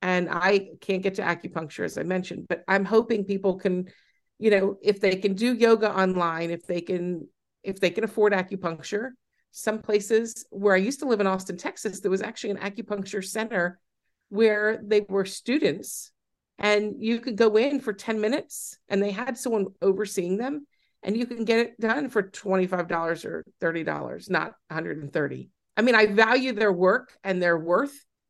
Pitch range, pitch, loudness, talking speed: 185-225 Hz, 200 Hz, -25 LUFS, 180 wpm